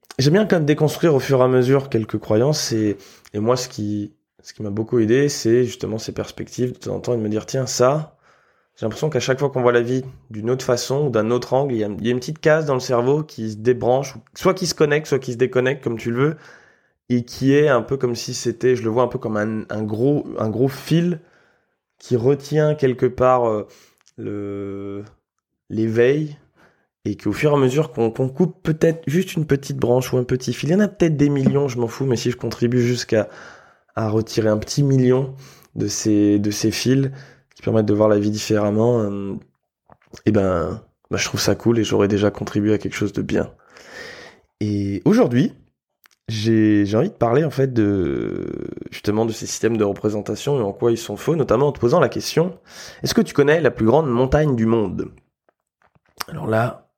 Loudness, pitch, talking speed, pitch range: -20 LUFS, 120 Hz, 225 wpm, 110-140 Hz